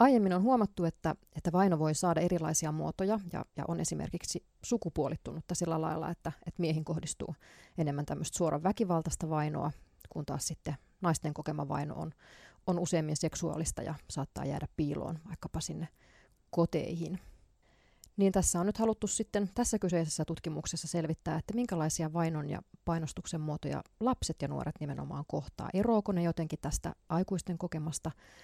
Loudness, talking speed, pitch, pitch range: -34 LUFS, 150 wpm, 165 Hz, 155-180 Hz